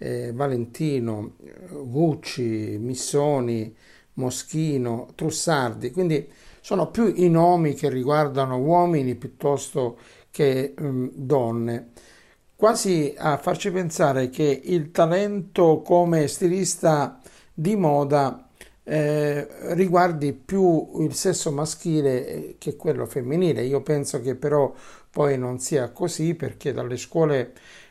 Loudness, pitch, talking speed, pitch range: -23 LUFS, 145 Hz, 105 wpm, 130-165 Hz